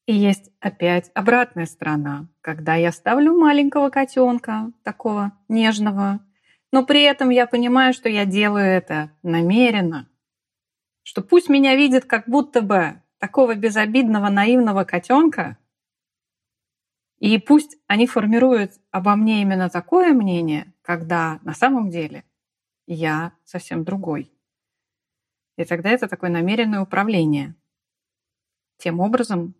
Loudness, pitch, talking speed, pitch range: -18 LUFS, 205 Hz, 115 wpm, 170-245 Hz